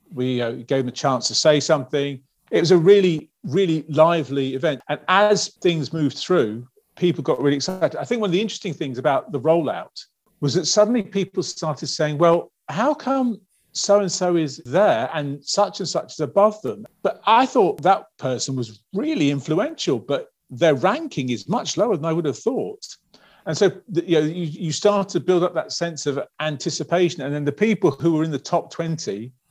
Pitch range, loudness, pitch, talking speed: 145-190 Hz, -21 LUFS, 160 Hz, 200 wpm